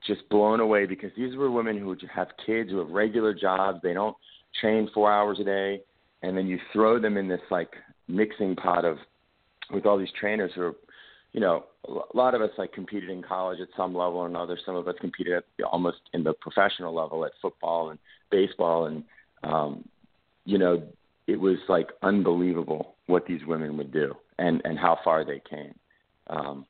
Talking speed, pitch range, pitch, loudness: 195 wpm, 90-105 Hz, 95 Hz, -27 LUFS